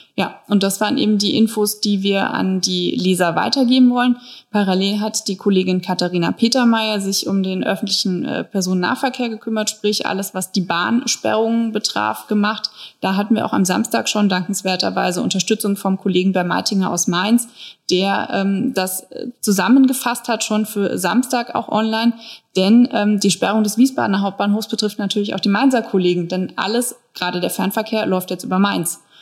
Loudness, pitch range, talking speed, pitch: -18 LUFS, 190-225 Hz, 165 wpm, 205 Hz